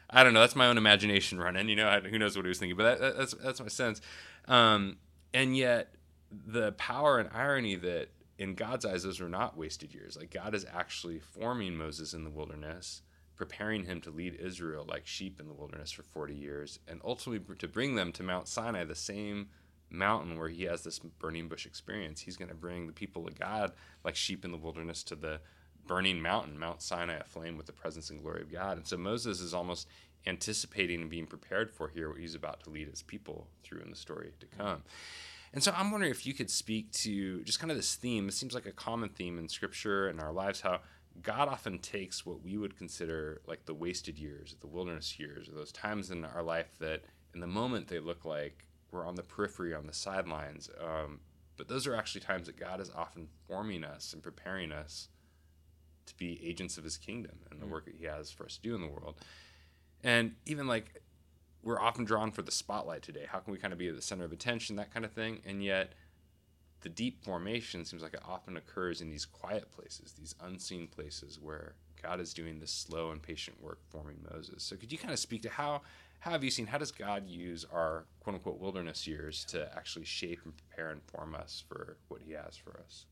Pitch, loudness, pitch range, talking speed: 85 Hz, -35 LUFS, 80-100 Hz, 225 wpm